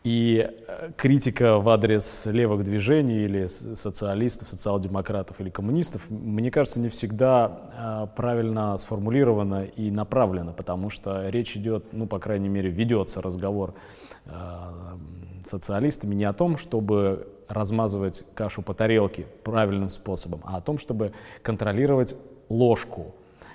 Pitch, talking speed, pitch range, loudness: 105 Hz, 120 wpm, 95-115 Hz, -25 LUFS